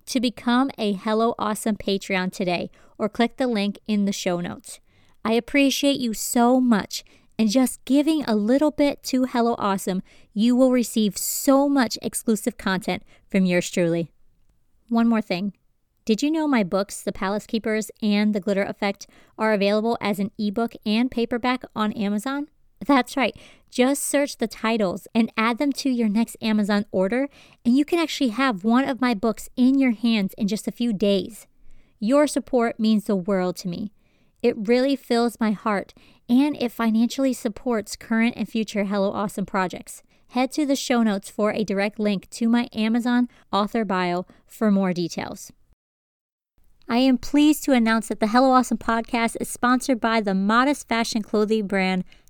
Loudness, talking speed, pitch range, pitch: -23 LUFS, 175 wpm, 205-250 Hz, 225 Hz